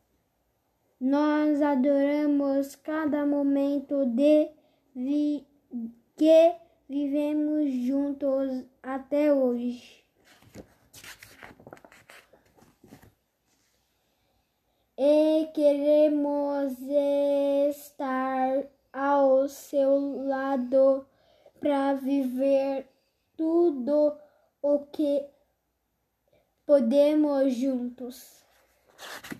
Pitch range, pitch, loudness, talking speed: 270-295 Hz, 280 Hz, -26 LUFS, 50 wpm